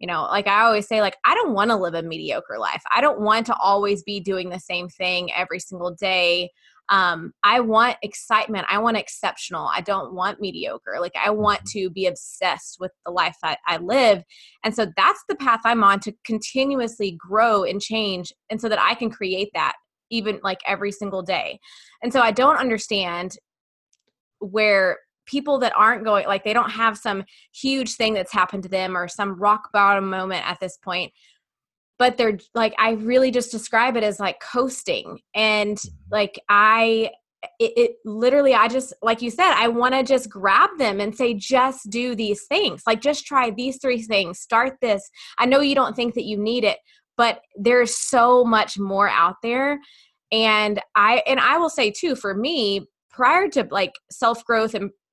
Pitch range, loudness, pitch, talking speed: 200-245 Hz, -20 LUFS, 215 Hz, 190 wpm